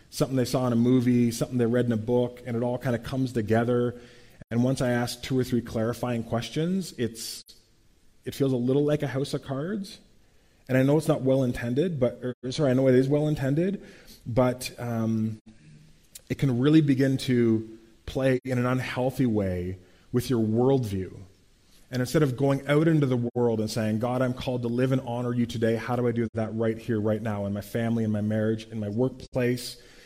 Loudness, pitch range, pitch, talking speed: -26 LUFS, 115-130 Hz, 120 Hz, 210 wpm